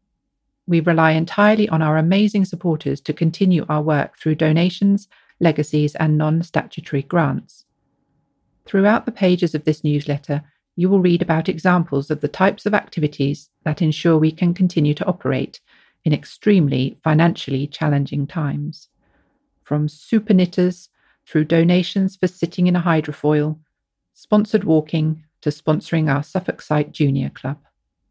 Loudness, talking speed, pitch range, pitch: -19 LUFS, 140 wpm, 150-180 Hz, 160 Hz